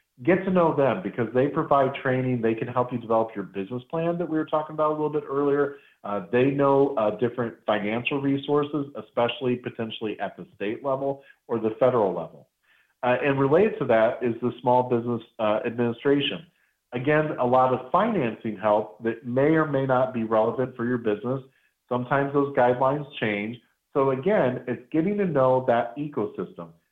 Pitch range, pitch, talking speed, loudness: 115-140 Hz, 125 Hz, 180 wpm, -25 LUFS